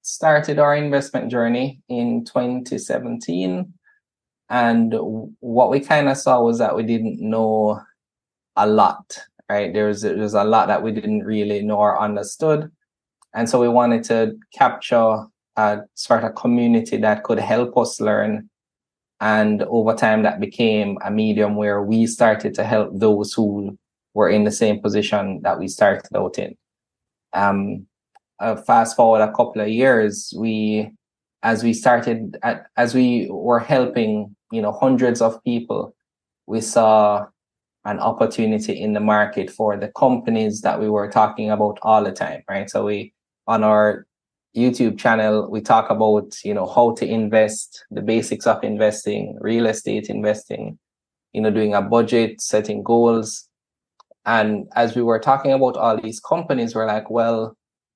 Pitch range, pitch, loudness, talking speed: 105-120 Hz, 110 Hz, -19 LUFS, 160 wpm